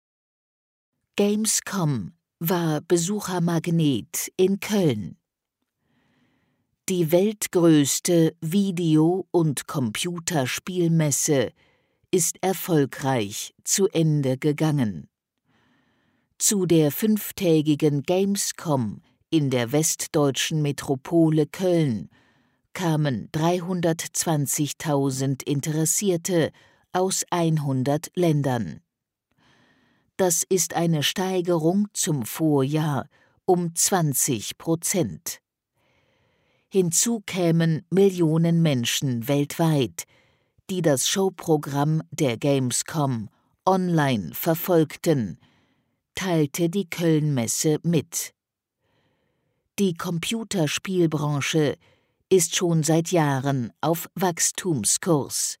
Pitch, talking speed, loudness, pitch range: 160 Hz, 70 wpm, -23 LUFS, 145-180 Hz